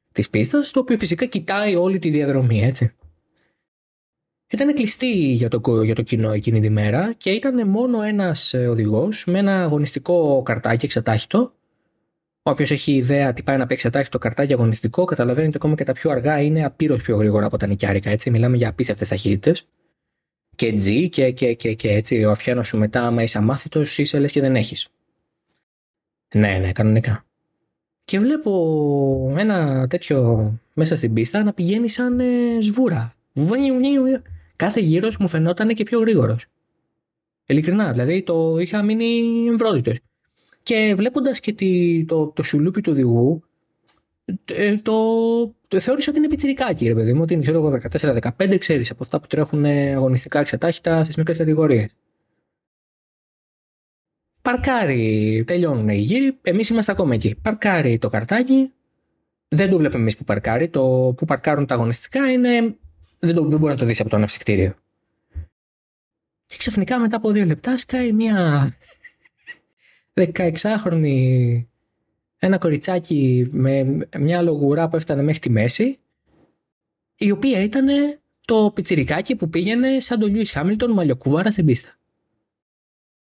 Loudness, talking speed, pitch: -19 LUFS, 145 wpm, 155 Hz